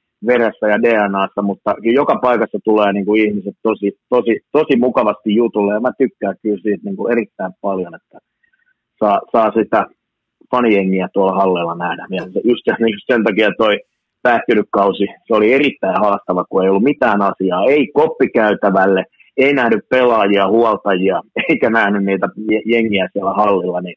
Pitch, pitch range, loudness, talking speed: 105 Hz, 100-115 Hz, -15 LUFS, 155 wpm